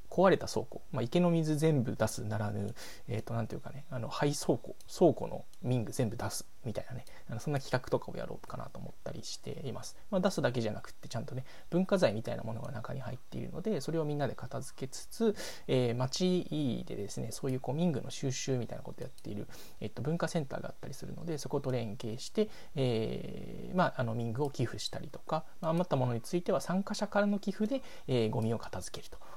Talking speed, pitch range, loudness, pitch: 430 characters per minute, 120-165 Hz, -35 LUFS, 135 Hz